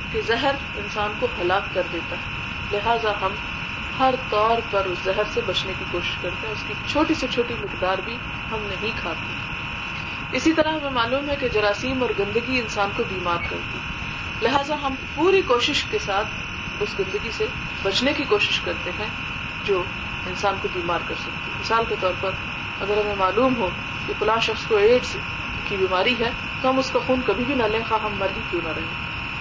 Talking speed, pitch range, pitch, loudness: 195 wpm, 200-270 Hz, 230 Hz, -23 LUFS